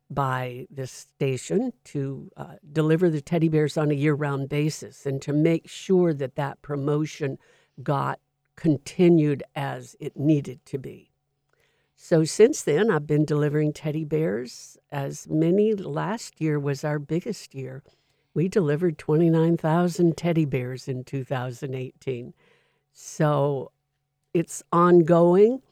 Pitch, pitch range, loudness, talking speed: 150 Hz, 140-165 Hz, -24 LUFS, 125 wpm